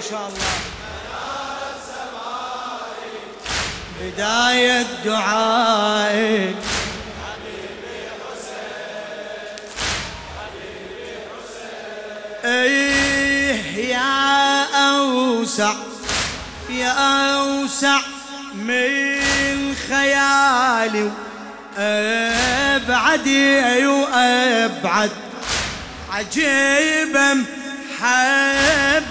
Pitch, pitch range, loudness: 250 Hz, 220-275 Hz, -17 LUFS